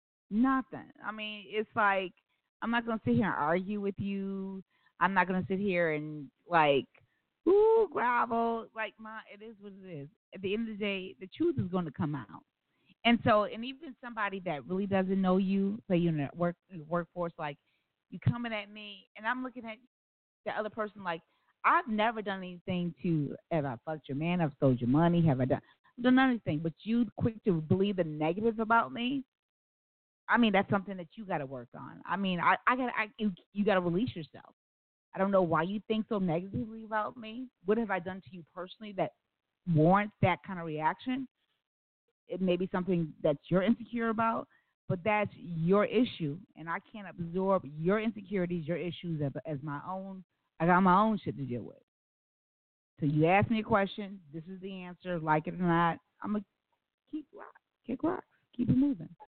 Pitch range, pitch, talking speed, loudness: 170-220 Hz, 190 Hz, 200 wpm, -31 LUFS